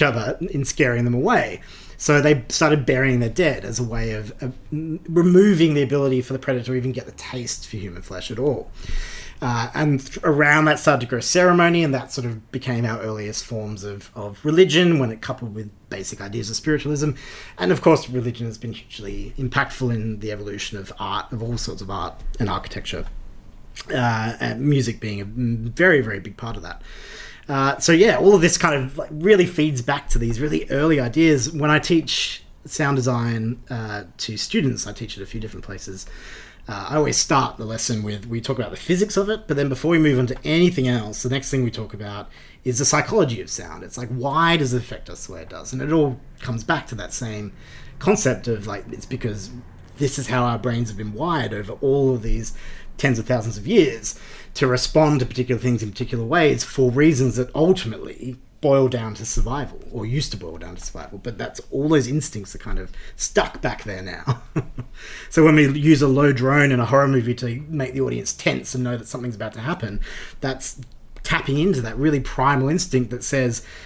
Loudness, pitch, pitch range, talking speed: -21 LUFS, 125 Hz, 110-145 Hz, 215 wpm